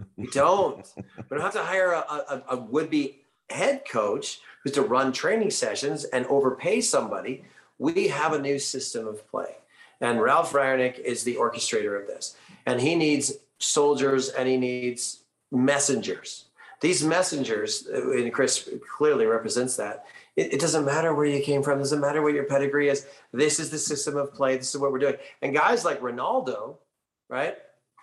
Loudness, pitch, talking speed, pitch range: -25 LUFS, 145 Hz, 180 wpm, 135-185 Hz